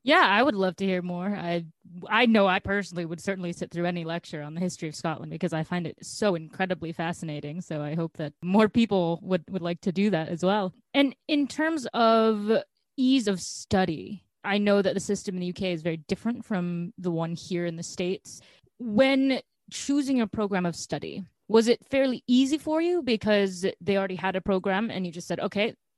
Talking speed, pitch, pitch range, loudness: 210 wpm, 190 Hz, 175-220 Hz, -27 LUFS